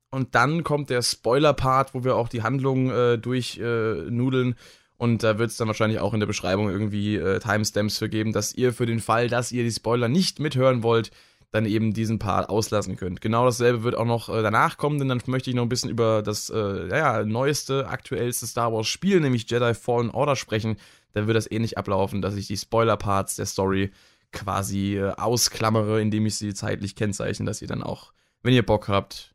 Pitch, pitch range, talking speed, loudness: 110 Hz, 105-125 Hz, 210 wpm, -24 LUFS